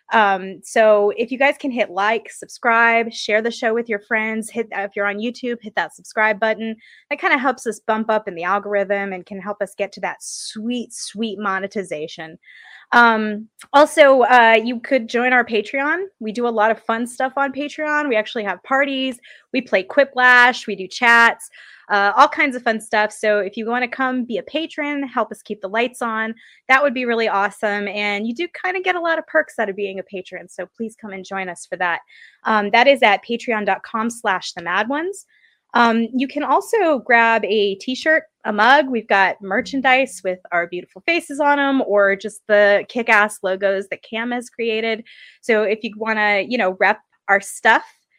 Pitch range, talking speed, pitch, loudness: 205-260 Hz, 205 wpm, 225 Hz, -18 LUFS